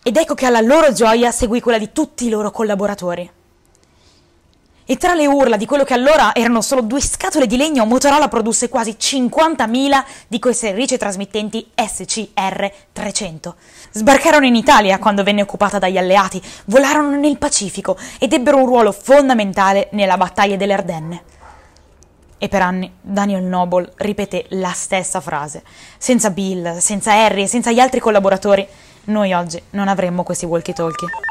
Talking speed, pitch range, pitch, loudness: 155 wpm, 190-250 Hz, 205 Hz, -15 LUFS